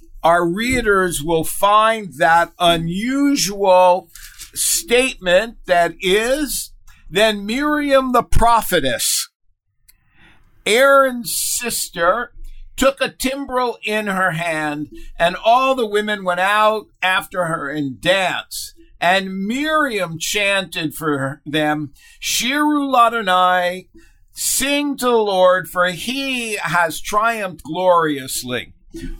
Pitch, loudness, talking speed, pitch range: 190 Hz, -17 LUFS, 100 wpm, 170-245 Hz